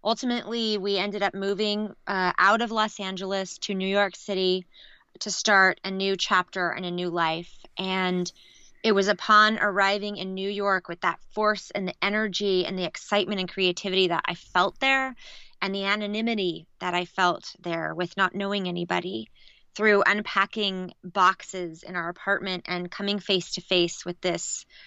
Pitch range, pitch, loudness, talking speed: 180-205 Hz, 195 Hz, -25 LUFS, 170 wpm